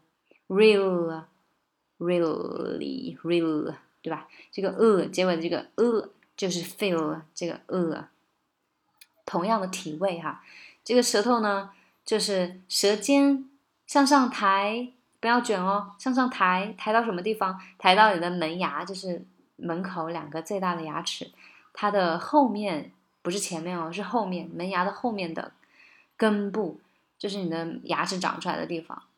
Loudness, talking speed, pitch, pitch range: -26 LUFS, 235 characters per minute, 195 Hz, 170-220 Hz